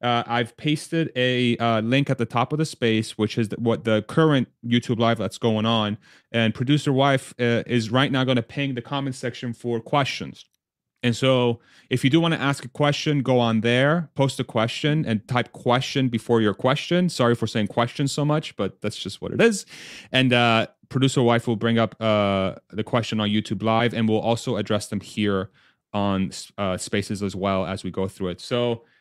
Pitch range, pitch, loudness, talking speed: 110-135 Hz, 120 Hz, -23 LUFS, 210 wpm